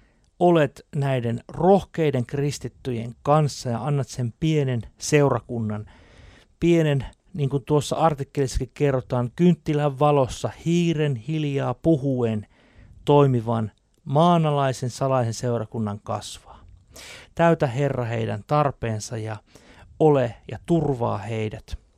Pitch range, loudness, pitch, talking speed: 115-150 Hz, -23 LUFS, 130 Hz, 95 wpm